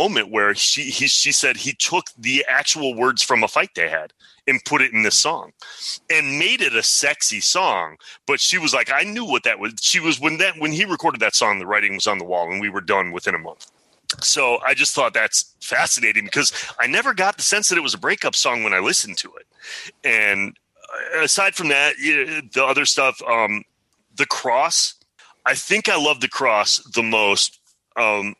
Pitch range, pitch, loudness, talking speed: 105-165 Hz, 145 Hz, -18 LUFS, 220 wpm